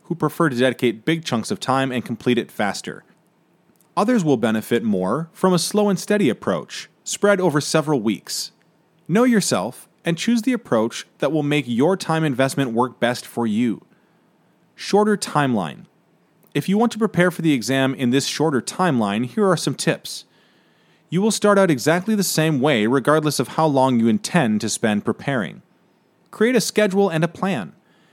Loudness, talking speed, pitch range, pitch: -20 LUFS, 175 wpm, 135-205 Hz, 165 Hz